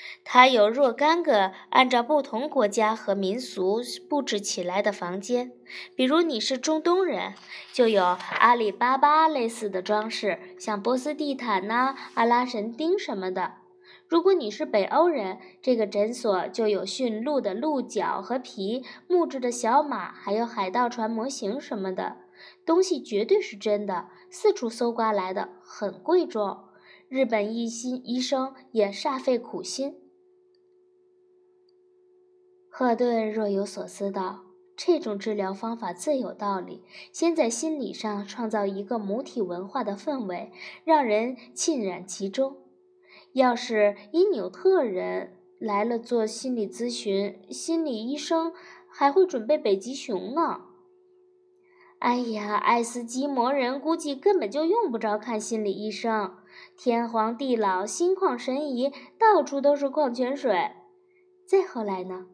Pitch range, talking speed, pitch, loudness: 210-315 Hz, 210 characters per minute, 245 Hz, -26 LUFS